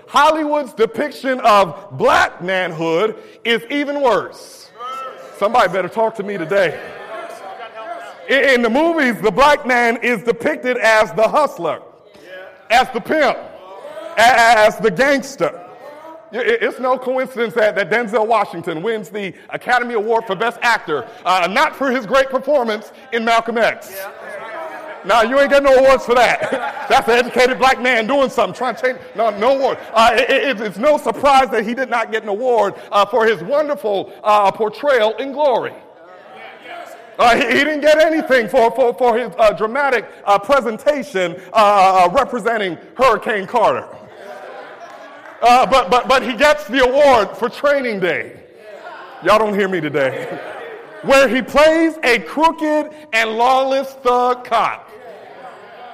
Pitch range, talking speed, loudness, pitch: 220-280 Hz, 150 wpm, -15 LUFS, 245 Hz